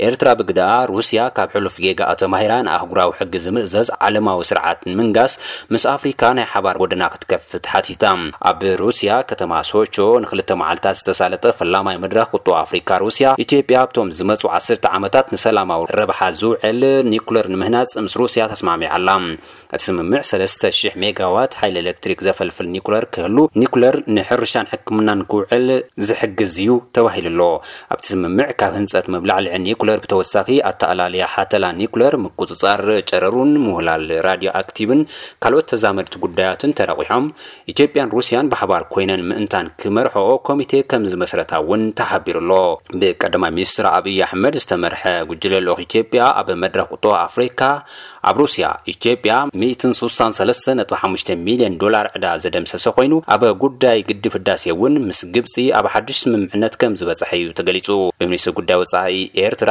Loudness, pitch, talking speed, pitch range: -16 LUFS, 115 Hz, 135 wpm, 95-130 Hz